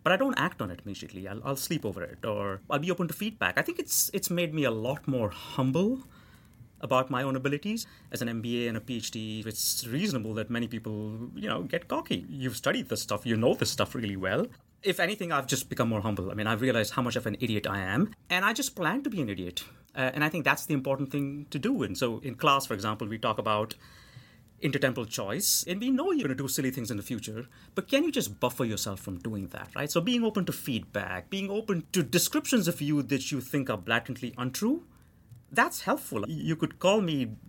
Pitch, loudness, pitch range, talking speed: 130 Hz, -30 LUFS, 110-165 Hz, 240 wpm